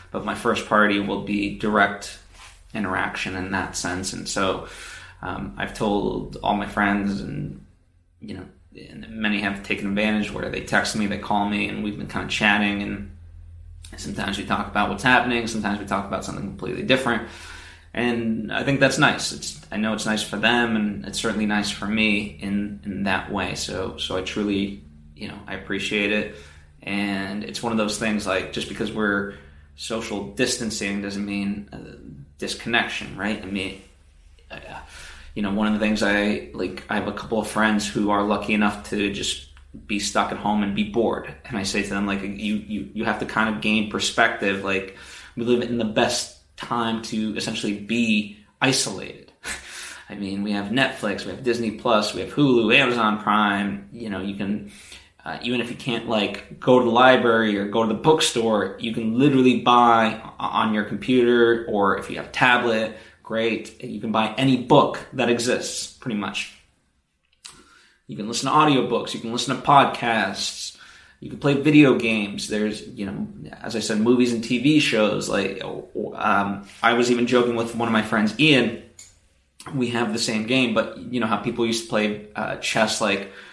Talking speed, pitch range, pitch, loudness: 190 wpm, 100-115 Hz, 105 Hz, -22 LUFS